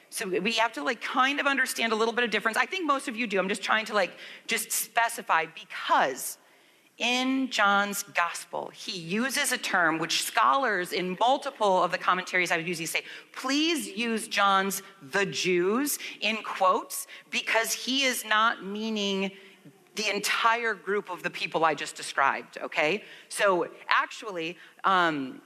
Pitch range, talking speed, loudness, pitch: 190-250 Hz, 165 wpm, -27 LUFS, 215 Hz